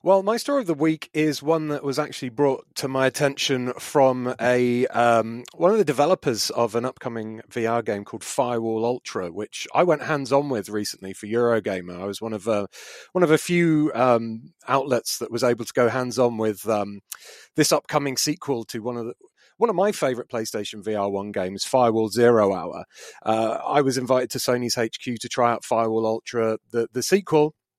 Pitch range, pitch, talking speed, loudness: 115-140 Hz, 125 Hz, 200 wpm, -23 LUFS